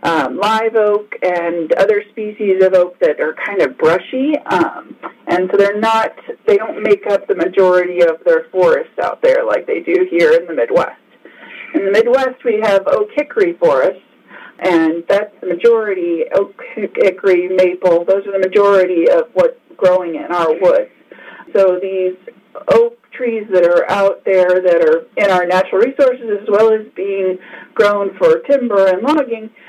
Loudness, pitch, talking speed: -14 LUFS, 215 Hz, 170 wpm